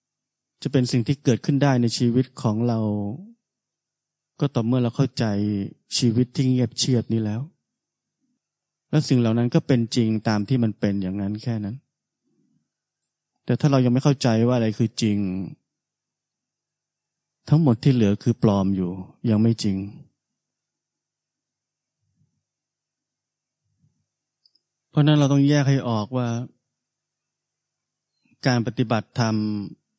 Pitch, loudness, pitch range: 120 Hz, -22 LUFS, 110-140 Hz